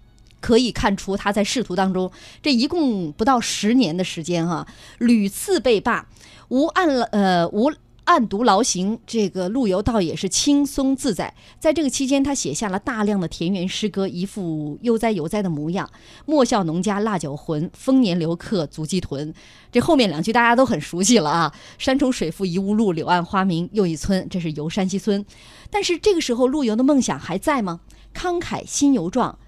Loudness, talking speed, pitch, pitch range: -20 LUFS, 275 characters per minute, 205 Hz, 180-260 Hz